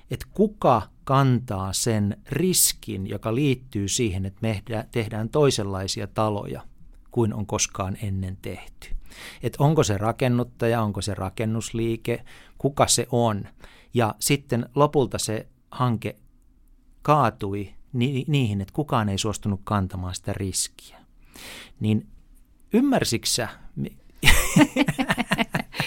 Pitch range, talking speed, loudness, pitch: 100-130 Hz, 105 wpm, -24 LUFS, 115 Hz